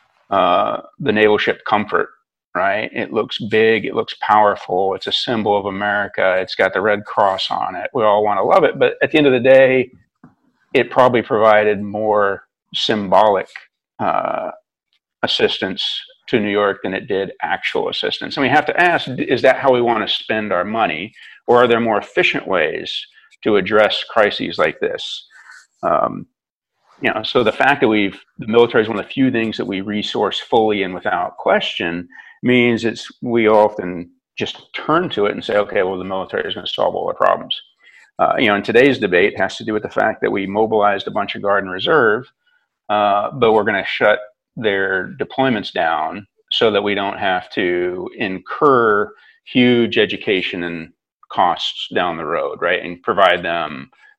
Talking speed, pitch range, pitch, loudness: 190 wpm, 100-130 Hz, 110 Hz, -17 LUFS